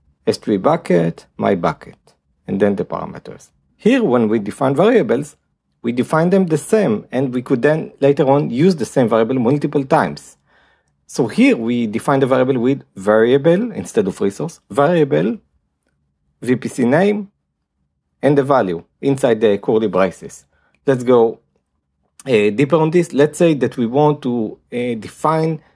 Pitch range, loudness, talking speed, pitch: 110-155 Hz, -16 LUFS, 150 wpm, 135 Hz